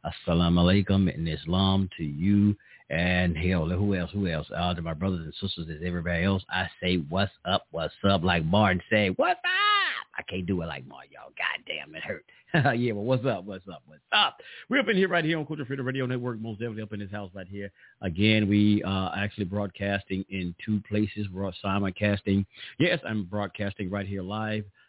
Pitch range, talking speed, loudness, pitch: 90-110 Hz, 210 wpm, -27 LUFS, 100 Hz